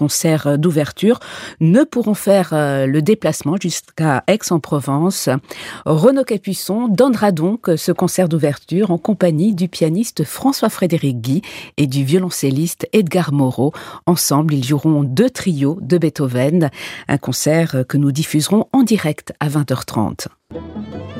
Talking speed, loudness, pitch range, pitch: 125 wpm, -16 LUFS, 145-190 Hz, 165 Hz